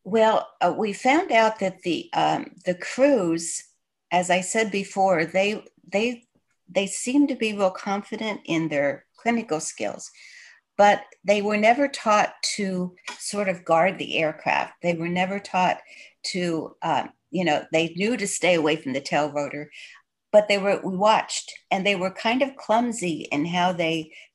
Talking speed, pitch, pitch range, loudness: 170 wpm, 195 Hz, 175-225 Hz, -23 LUFS